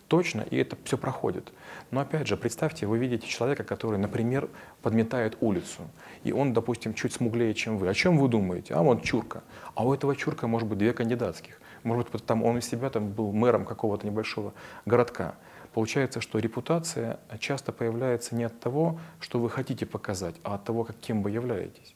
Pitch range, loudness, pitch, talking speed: 110-130 Hz, -29 LUFS, 115 Hz, 190 wpm